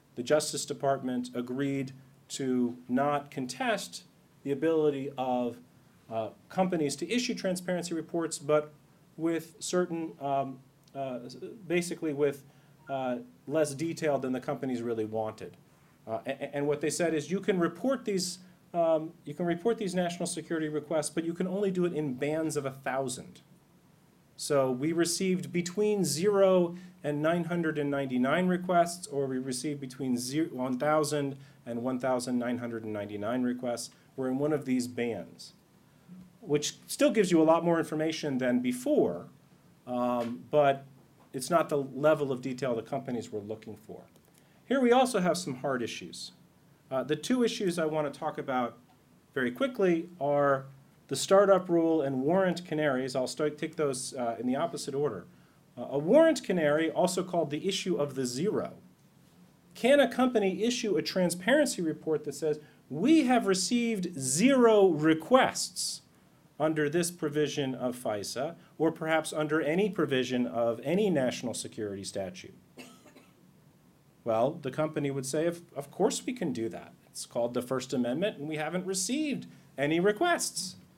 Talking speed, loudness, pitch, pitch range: 150 wpm, -30 LUFS, 150 Hz, 135-175 Hz